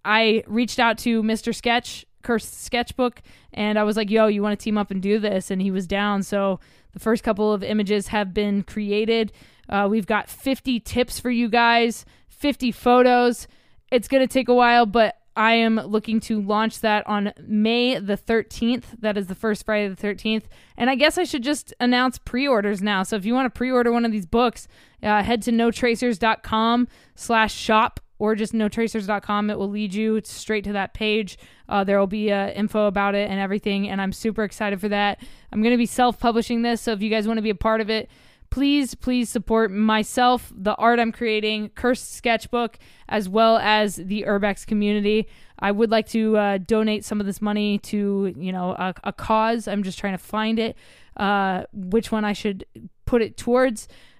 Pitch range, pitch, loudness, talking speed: 205-235 Hz, 220 Hz, -22 LUFS, 200 wpm